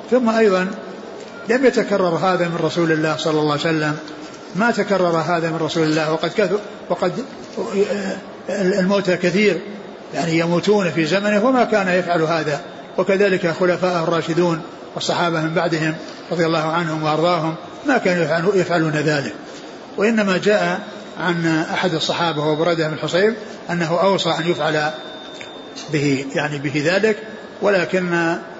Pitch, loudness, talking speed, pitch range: 175 Hz, -19 LUFS, 130 wpm, 160-195 Hz